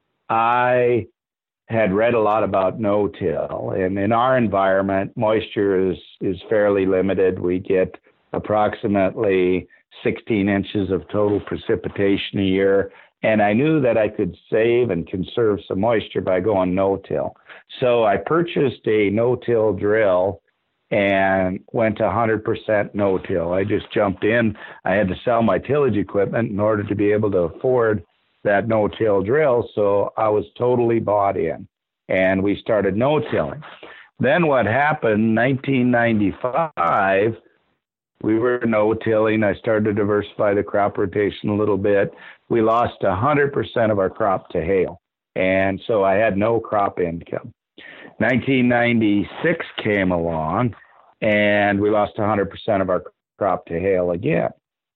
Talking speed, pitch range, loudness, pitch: 145 wpm, 95-110 Hz, -20 LUFS, 105 Hz